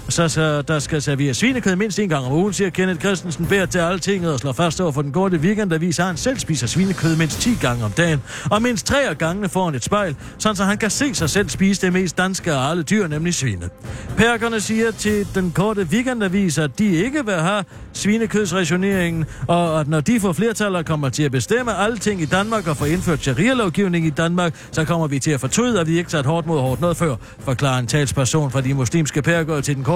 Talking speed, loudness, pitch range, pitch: 230 wpm, -19 LUFS, 150-200 Hz, 170 Hz